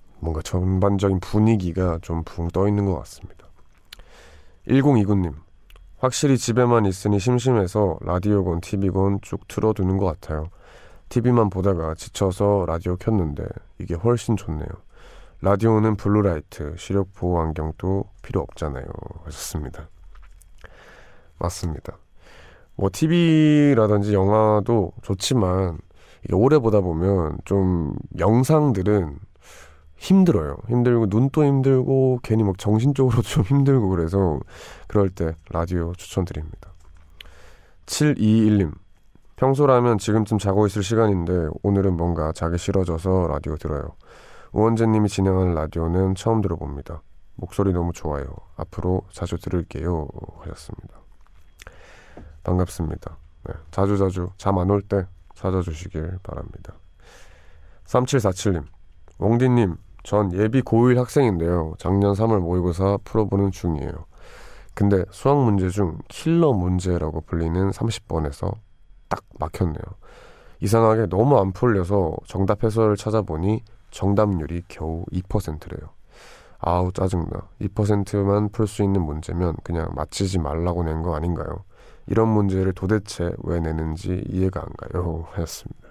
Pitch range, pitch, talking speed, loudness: 85-105 Hz, 95 Hz, 275 characters per minute, -22 LUFS